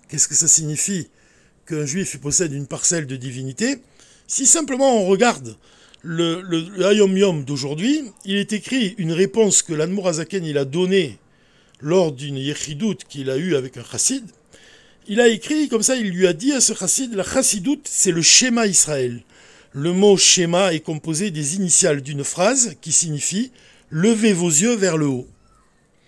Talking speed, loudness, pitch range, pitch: 175 wpm, -18 LUFS, 150-215 Hz, 180 Hz